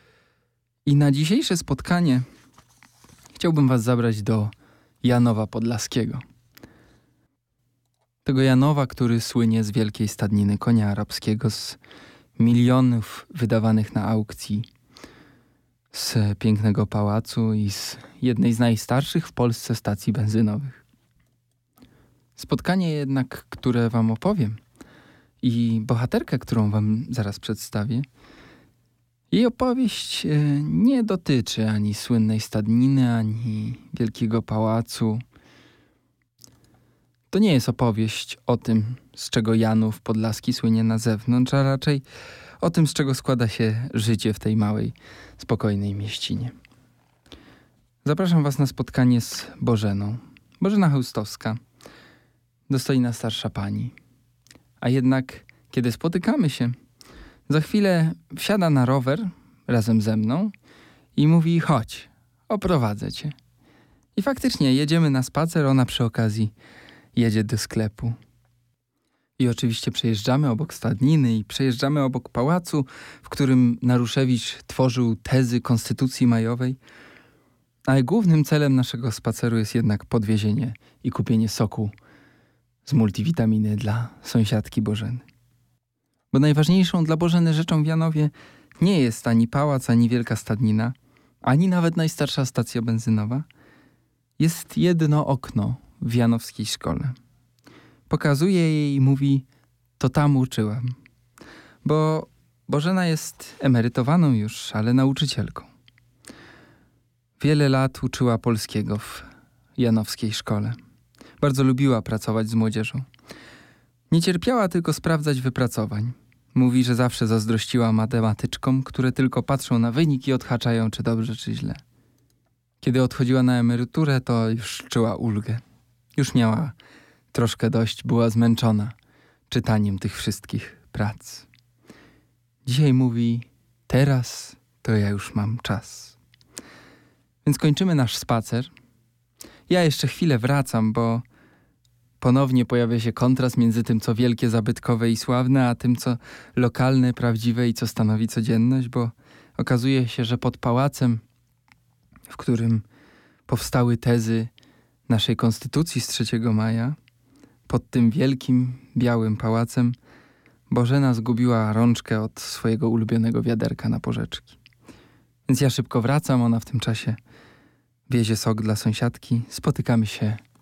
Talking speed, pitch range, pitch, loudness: 115 wpm, 115-135 Hz, 120 Hz, -22 LUFS